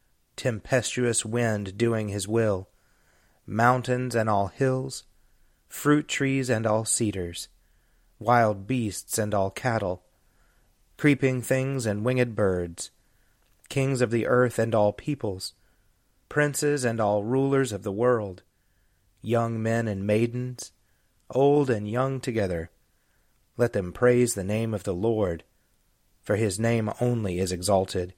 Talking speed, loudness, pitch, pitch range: 130 wpm, -26 LUFS, 110 Hz, 100-125 Hz